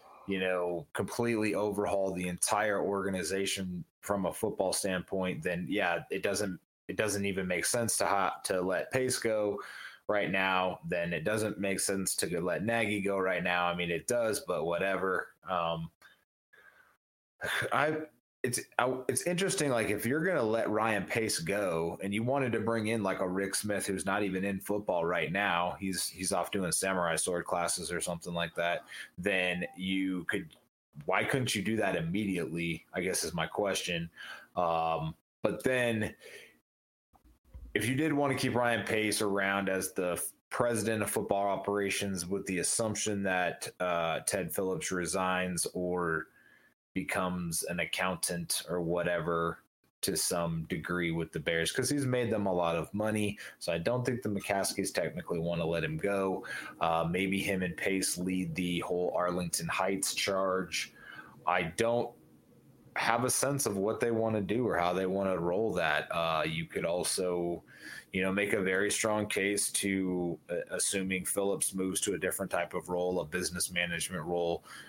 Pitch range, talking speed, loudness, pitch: 90-105 Hz, 170 wpm, -32 LUFS, 95 Hz